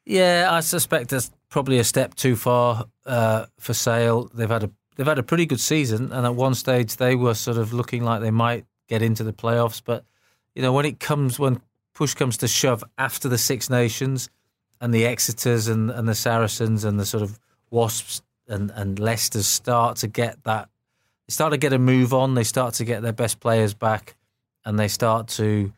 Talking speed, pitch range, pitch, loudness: 210 wpm, 110-130 Hz, 120 Hz, -22 LUFS